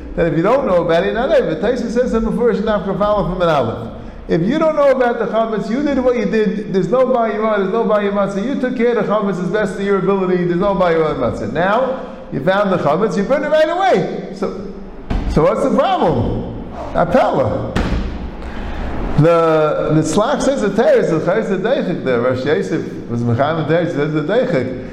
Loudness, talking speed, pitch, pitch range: -16 LUFS, 200 wpm, 200 Hz, 165-230 Hz